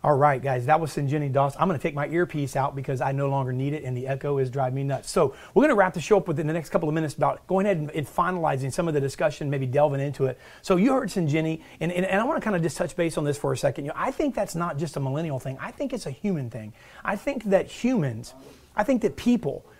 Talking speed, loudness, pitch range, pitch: 295 wpm, -25 LUFS, 140-185 Hz, 155 Hz